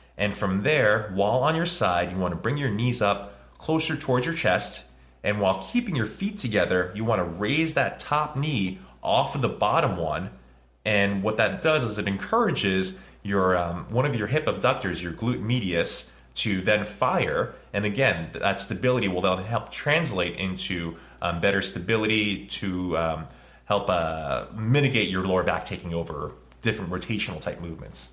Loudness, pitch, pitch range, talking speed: -25 LUFS, 100 Hz, 85-120 Hz, 175 wpm